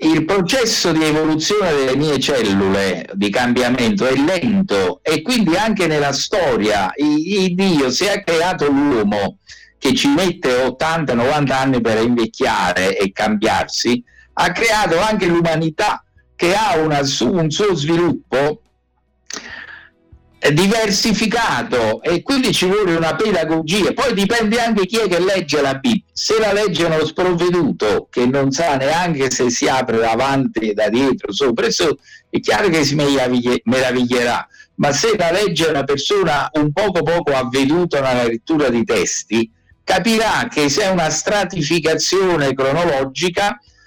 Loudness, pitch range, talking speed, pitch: -16 LUFS, 130-195 Hz, 135 wpm, 155 Hz